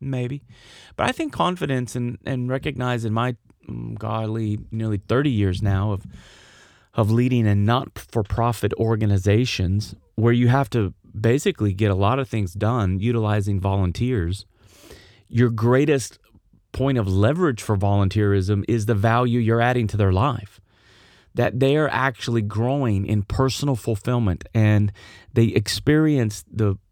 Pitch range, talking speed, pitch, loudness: 100-125 Hz, 140 wpm, 110 Hz, -22 LUFS